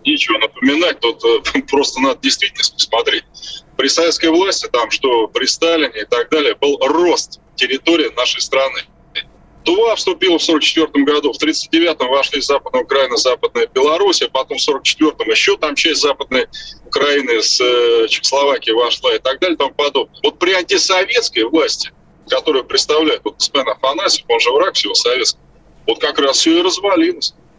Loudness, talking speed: -14 LUFS, 160 wpm